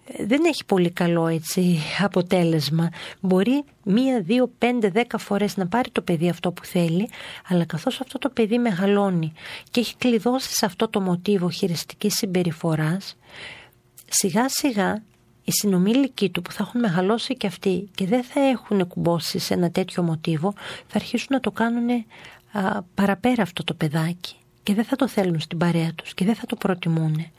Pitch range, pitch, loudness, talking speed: 175-230 Hz, 195 Hz, -23 LUFS, 165 wpm